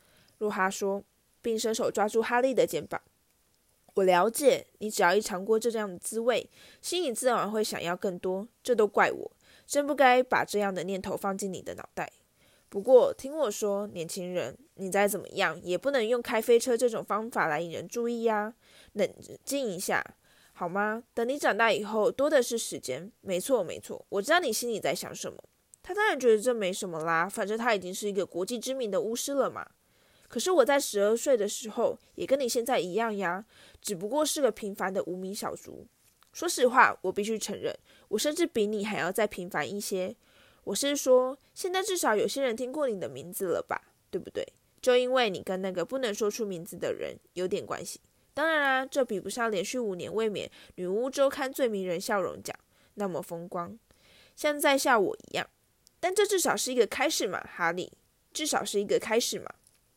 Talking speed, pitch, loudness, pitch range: 290 characters per minute, 220 Hz, -29 LUFS, 195-265 Hz